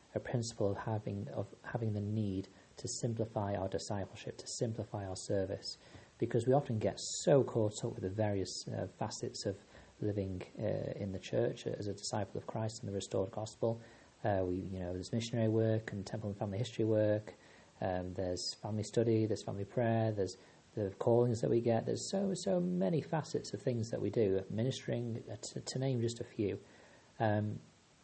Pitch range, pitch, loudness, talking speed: 100-120 Hz, 110 Hz, -37 LUFS, 190 wpm